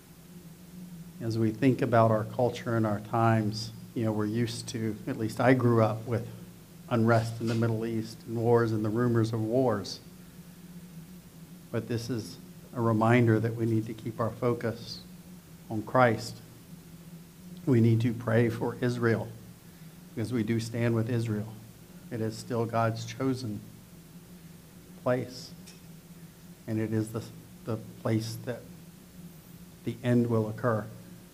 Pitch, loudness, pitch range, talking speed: 120 Hz, -29 LUFS, 115-170 Hz, 145 wpm